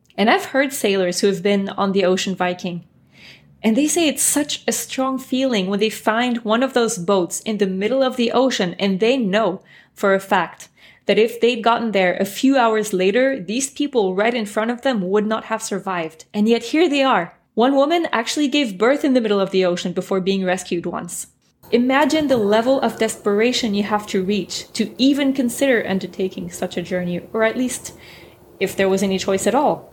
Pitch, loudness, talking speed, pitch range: 220 Hz, -19 LUFS, 210 wpm, 195-255 Hz